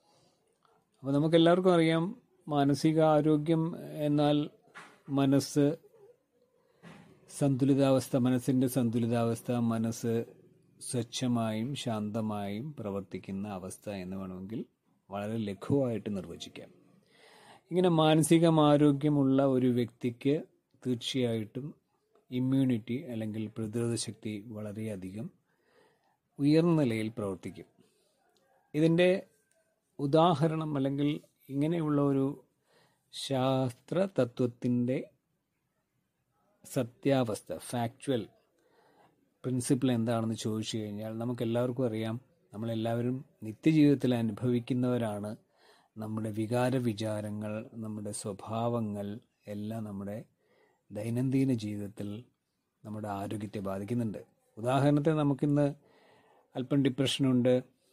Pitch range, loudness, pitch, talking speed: 110-145 Hz, -31 LUFS, 125 Hz, 70 wpm